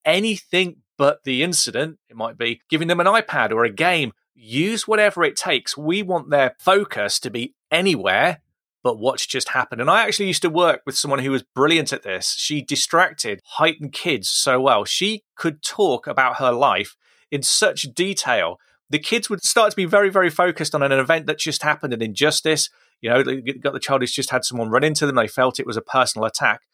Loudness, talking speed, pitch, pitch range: -19 LUFS, 210 wpm, 155 Hz, 135-180 Hz